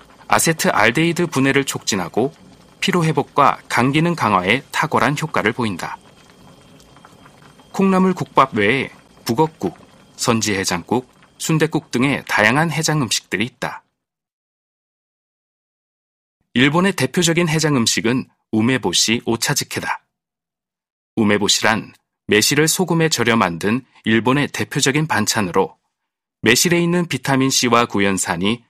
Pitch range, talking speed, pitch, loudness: 115-160 Hz, 265 characters per minute, 135 Hz, -17 LUFS